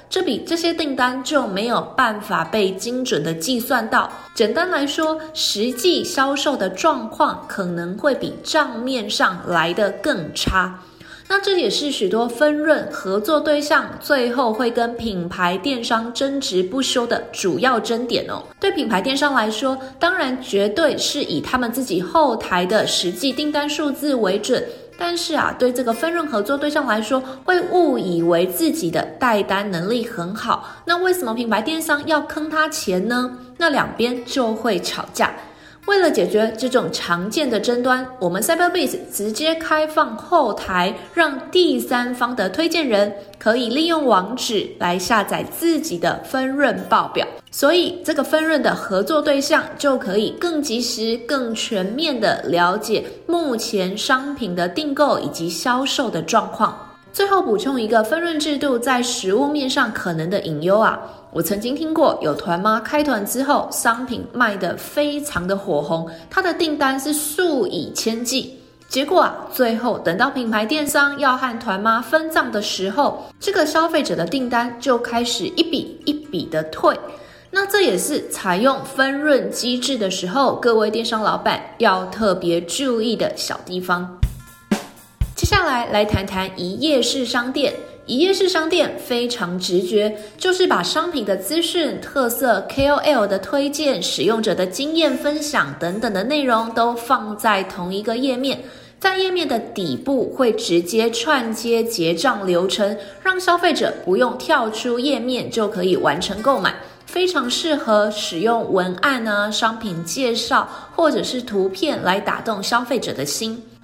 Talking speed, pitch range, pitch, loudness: 245 characters per minute, 210-300 Hz, 250 Hz, -19 LUFS